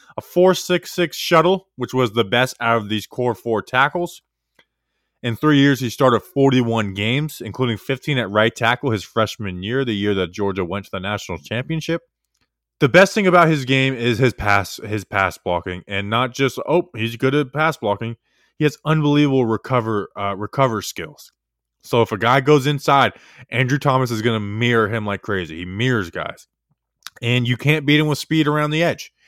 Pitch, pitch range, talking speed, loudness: 125 Hz, 105-145 Hz, 195 wpm, -19 LUFS